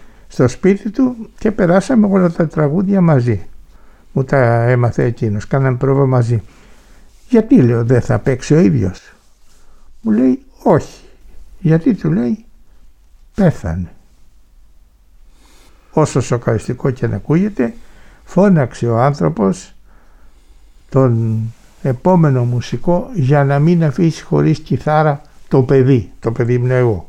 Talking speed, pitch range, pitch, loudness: 115 wpm, 115-170 Hz, 135 Hz, -15 LUFS